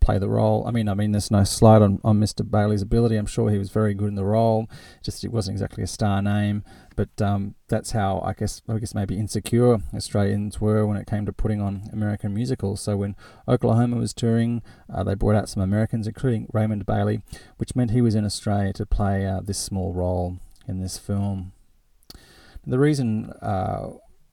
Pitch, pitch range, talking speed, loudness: 105 Hz, 100-110 Hz, 205 wpm, -23 LUFS